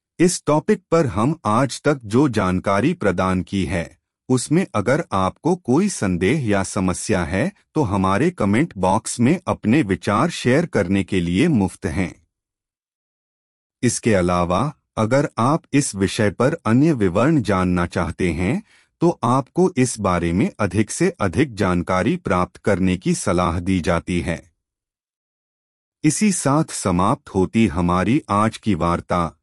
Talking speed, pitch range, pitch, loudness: 140 wpm, 90-145 Hz, 105 Hz, -20 LUFS